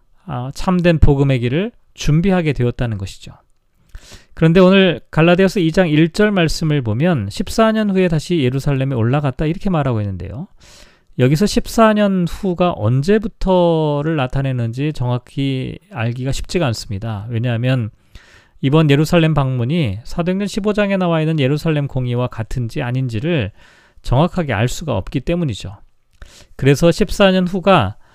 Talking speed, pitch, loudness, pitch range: 310 characters per minute, 150 Hz, -16 LUFS, 125-180 Hz